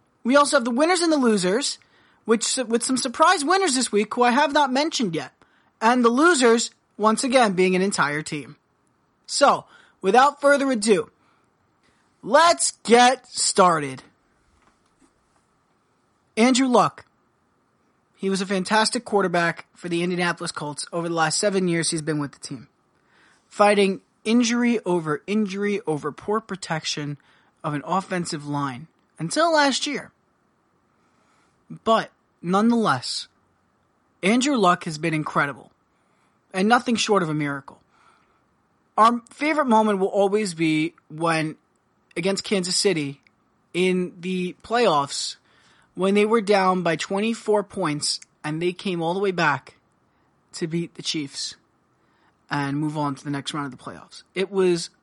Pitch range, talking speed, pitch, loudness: 165-235 Hz, 140 wpm, 195 Hz, -22 LUFS